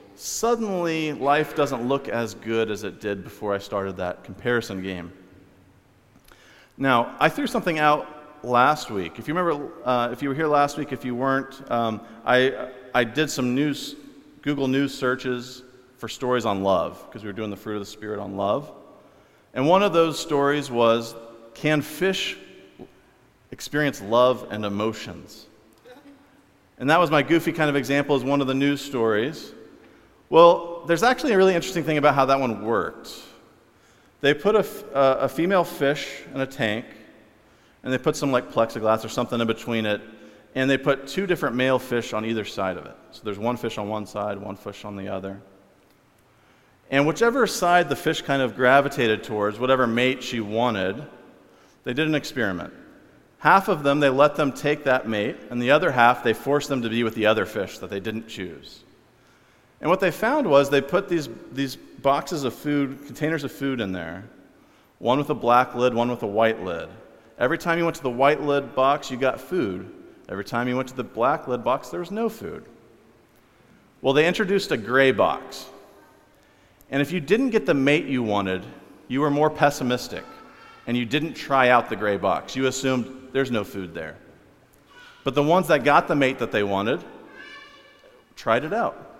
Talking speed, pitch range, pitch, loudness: 190 wpm, 110-145 Hz, 130 Hz, -23 LUFS